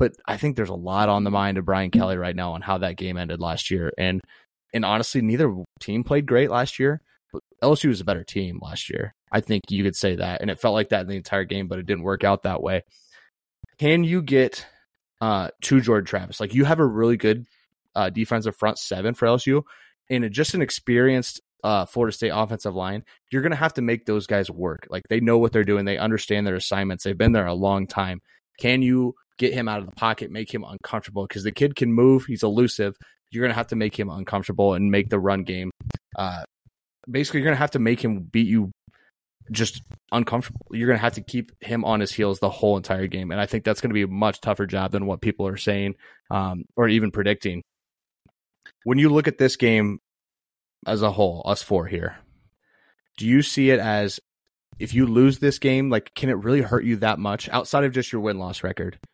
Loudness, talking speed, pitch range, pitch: -23 LUFS, 230 wpm, 100-125 Hz, 110 Hz